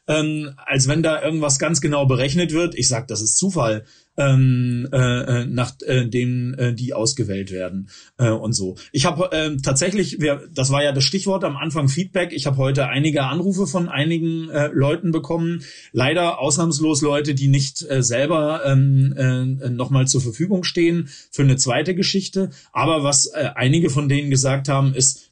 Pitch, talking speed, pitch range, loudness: 140 Hz, 180 wpm, 130-160 Hz, -19 LUFS